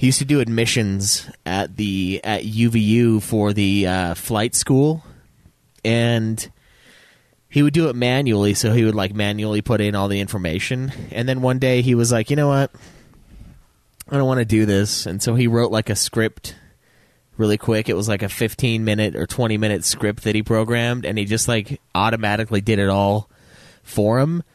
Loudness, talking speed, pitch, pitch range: -19 LUFS, 190 wpm, 110 Hz, 105-120 Hz